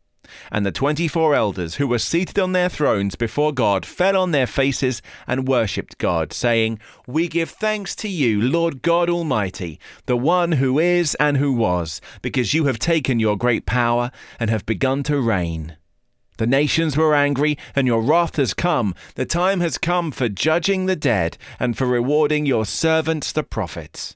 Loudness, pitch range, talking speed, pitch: -20 LUFS, 115-160 Hz, 180 wpm, 135 Hz